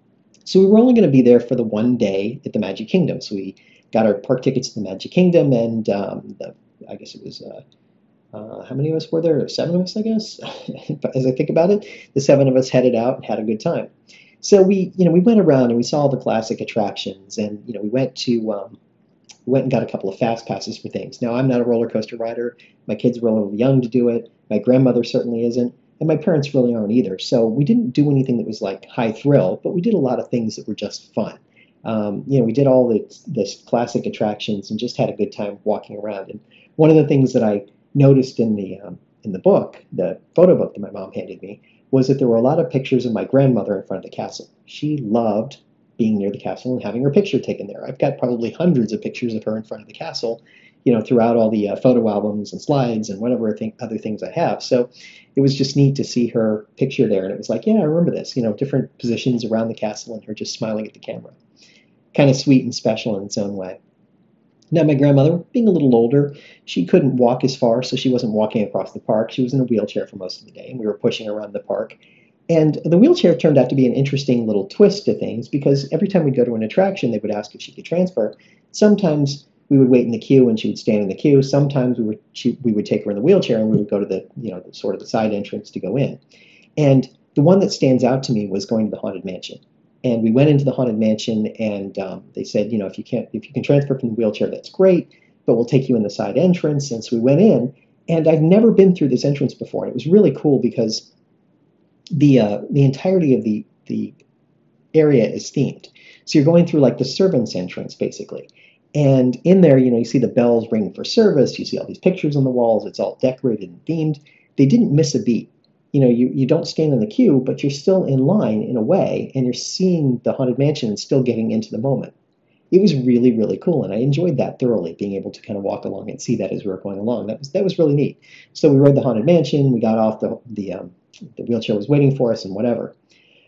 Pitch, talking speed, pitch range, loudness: 125 Hz, 260 wpm, 110-150 Hz, -18 LUFS